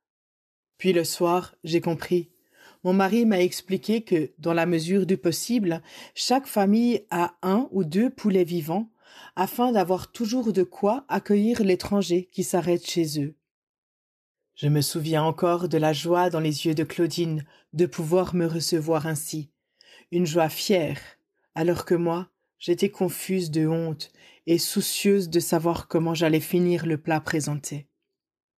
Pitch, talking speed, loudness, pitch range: 175 Hz, 150 wpm, -25 LUFS, 165-190 Hz